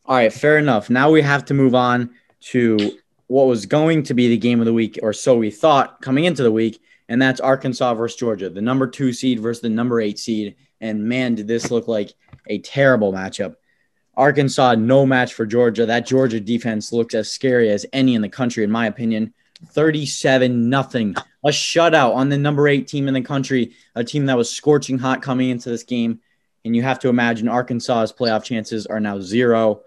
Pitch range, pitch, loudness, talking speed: 115-135 Hz, 125 Hz, -18 LUFS, 210 wpm